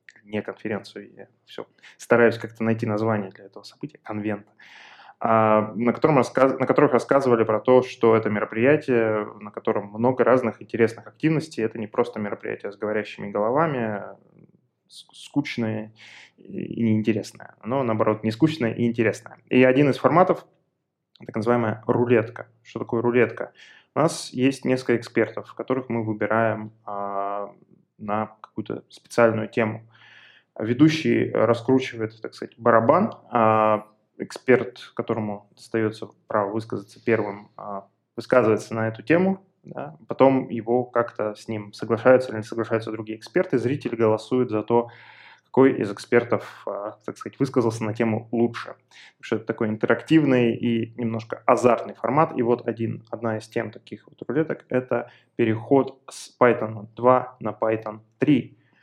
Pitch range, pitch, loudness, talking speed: 110-125 Hz, 115 Hz, -23 LUFS, 140 wpm